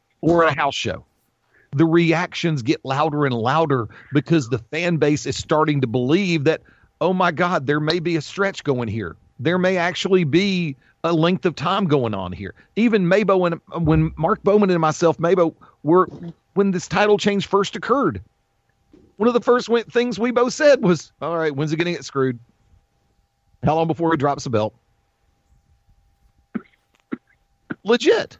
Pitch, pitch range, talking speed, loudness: 165 Hz, 135-185 Hz, 170 wpm, -20 LUFS